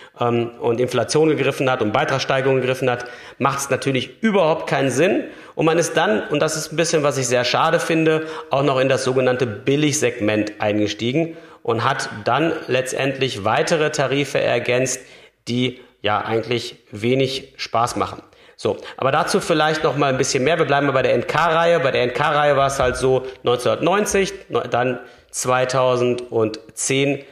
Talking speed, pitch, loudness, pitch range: 160 wpm, 130 Hz, -19 LUFS, 125-150 Hz